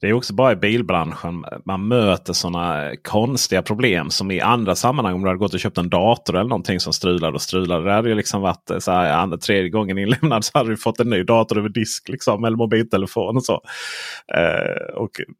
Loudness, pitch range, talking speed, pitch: -19 LUFS, 90-115 Hz, 220 wpm, 105 Hz